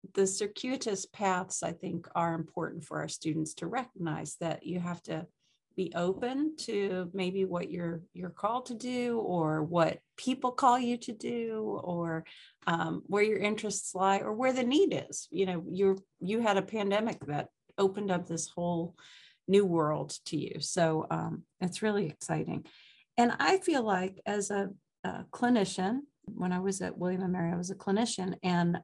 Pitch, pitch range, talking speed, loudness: 190 Hz, 175-215 Hz, 175 wpm, -32 LUFS